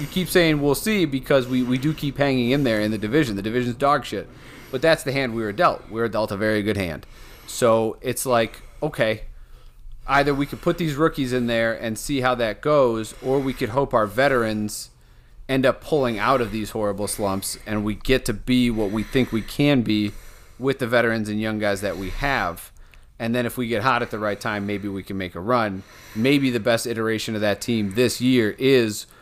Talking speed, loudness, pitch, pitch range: 230 wpm, -22 LUFS, 115 Hz, 105-130 Hz